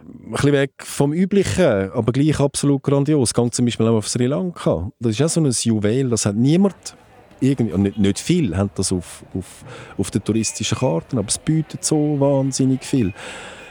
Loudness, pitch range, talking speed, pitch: -19 LUFS, 110-145 Hz, 190 wpm, 130 Hz